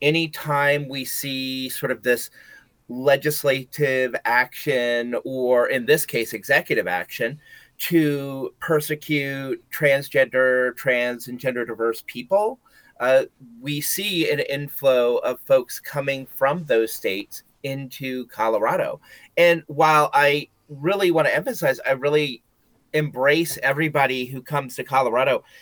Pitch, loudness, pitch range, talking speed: 140 Hz, -22 LUFS, 130-155 Hz, 115 wpm